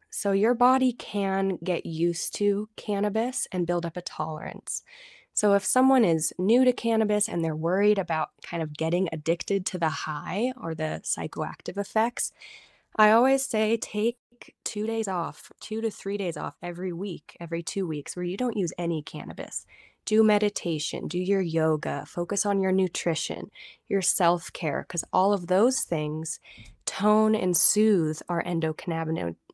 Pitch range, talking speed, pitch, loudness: 170-215 Hz, 165 wpm, 190 Hz, -26 LUFS